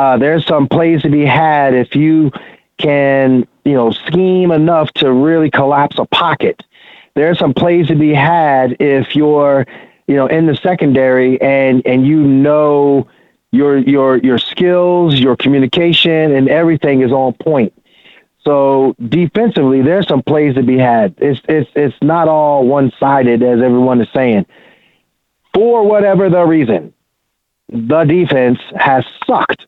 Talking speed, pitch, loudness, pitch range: 150 wpm, 145 Hz, -11 LUFS, 130-160 Hz